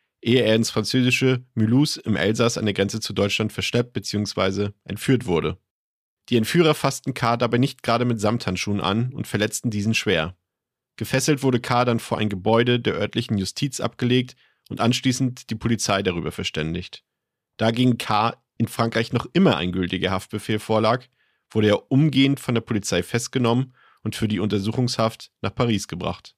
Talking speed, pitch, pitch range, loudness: 165 wpm, 115 Hz, 105-125 Hz, -22 LUFS